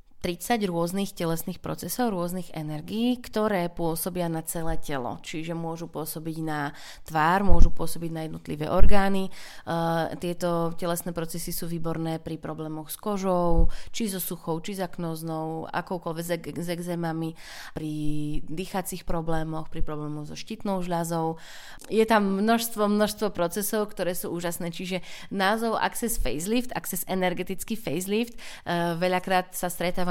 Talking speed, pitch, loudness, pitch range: 135 wpm, 175 Hz, -29 LUFS, 165-190 Hz